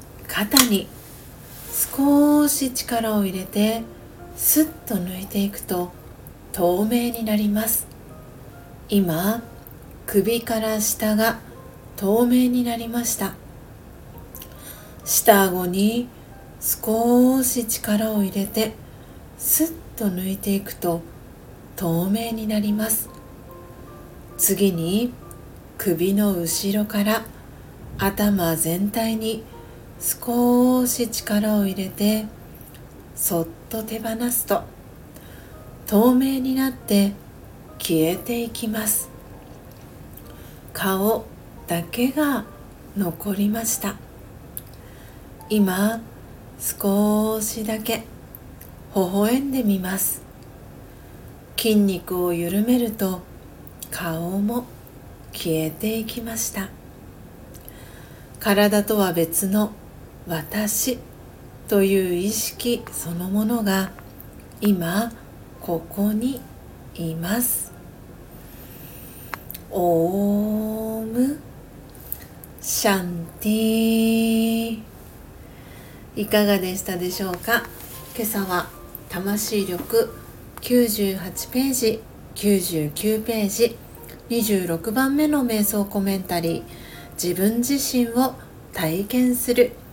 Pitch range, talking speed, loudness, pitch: 185-230 Hz, 145 characters per minute, -22 LUFS, 210 Hz